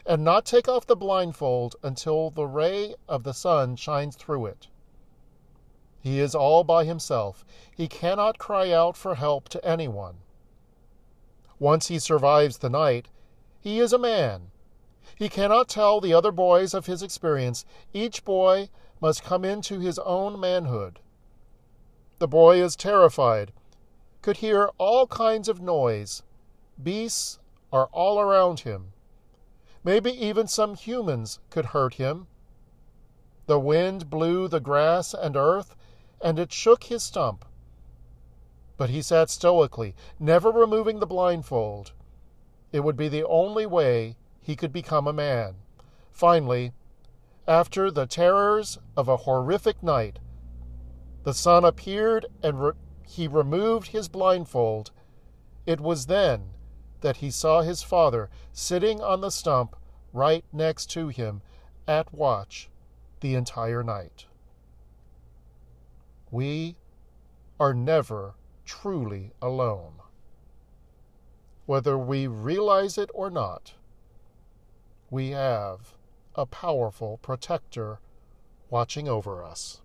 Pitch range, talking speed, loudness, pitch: 110-175 Hz, 125 wpm, -24 LUFS, 140 Hz